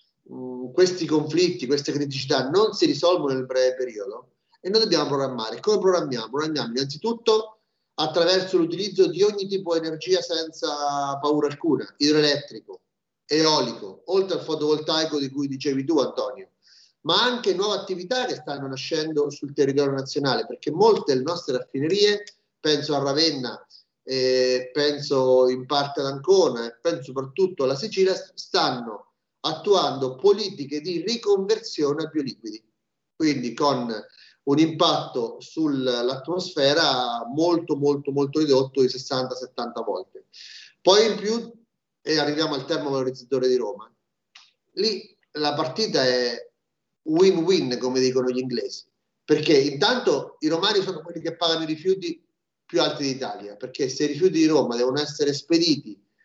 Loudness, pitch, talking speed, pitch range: -23 LUFS, 155 Hz, 135 wpm, 135-200 Hz